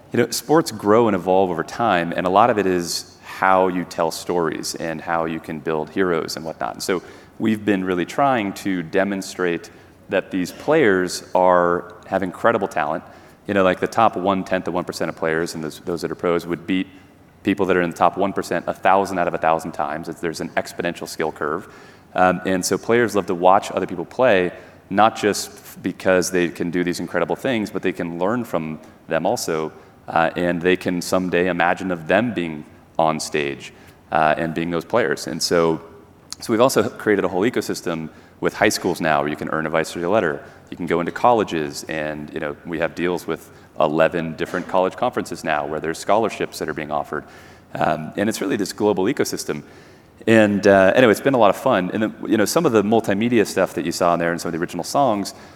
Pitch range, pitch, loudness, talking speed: 80-95 Hz, 90 Hz, -20 LUFS, 220 wpm